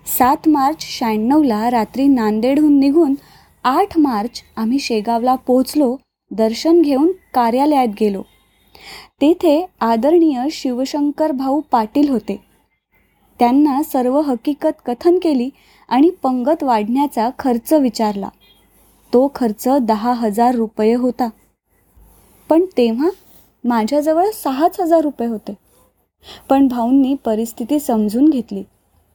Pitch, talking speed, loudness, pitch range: 260 Hz, 100 wpm, -16 LUFS, 235-295 Hz